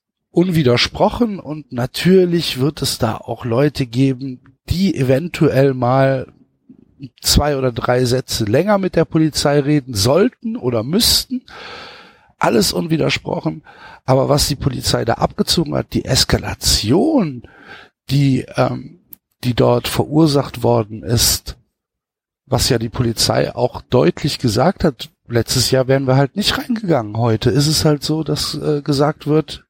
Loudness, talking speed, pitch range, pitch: -16 LUFS, 135 wpm, 125-160 Hz, 140 Hz